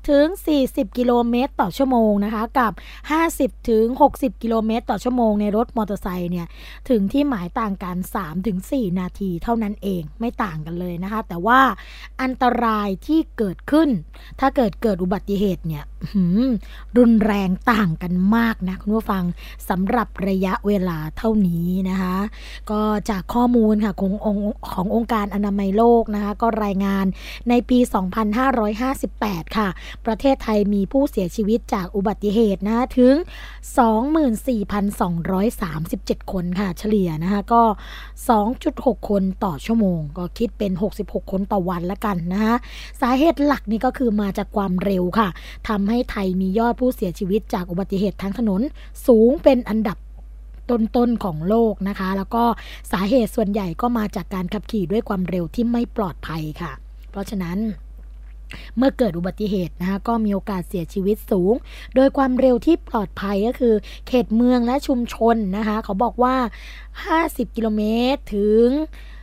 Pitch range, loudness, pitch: 195-240 Hz, -21 LUFS, 215 Hz